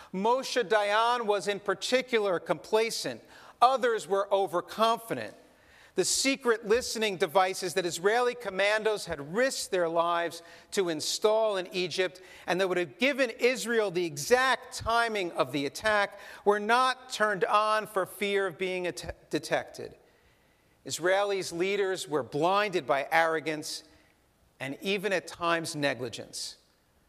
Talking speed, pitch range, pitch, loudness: 125 wpm, 170-225 Hz, 195 Hz, -28 LUFS